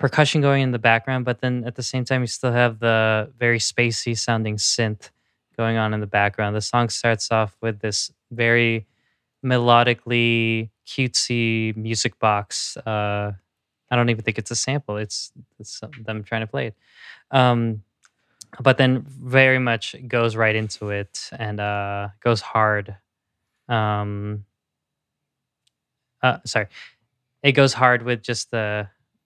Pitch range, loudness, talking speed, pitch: 105-125 Hz, -21 LUFS, 150 wpm, 115 Hz